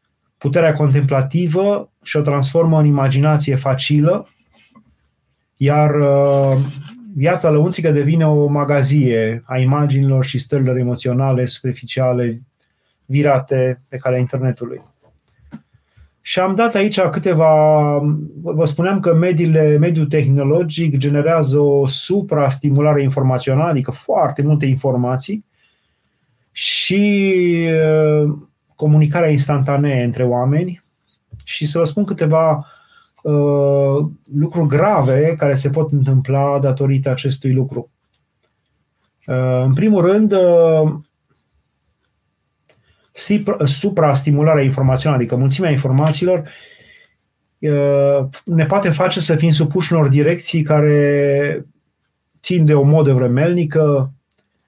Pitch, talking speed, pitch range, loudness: 145 Hz, 95 wpm, 135-160 Hz, -15 LUFS